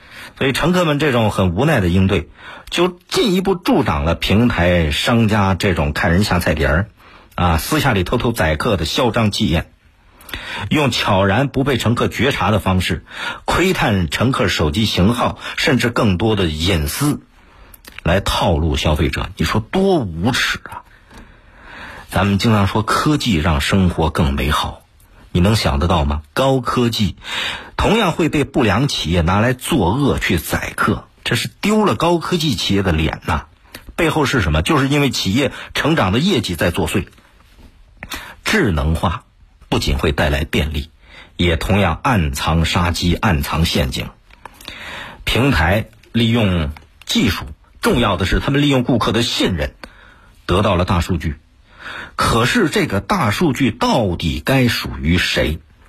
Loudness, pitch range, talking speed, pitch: -17 LUFS, 85-120 Hz, 230 characters per minute, 95 Hz